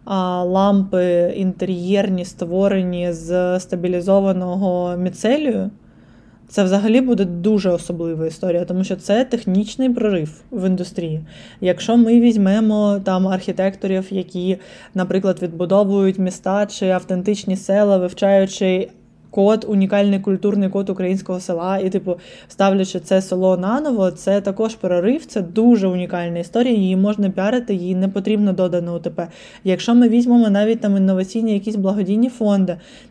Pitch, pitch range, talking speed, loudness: 190 Hz, 180-205 Hz, 125 wpm, -18 LUFS